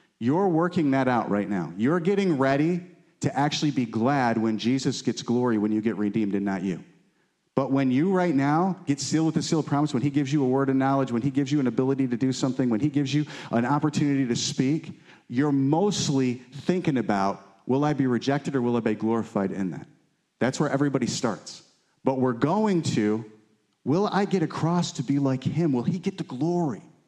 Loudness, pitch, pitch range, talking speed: -25 LUFS, 140 Hz, 125-160 Hz, 215 wpm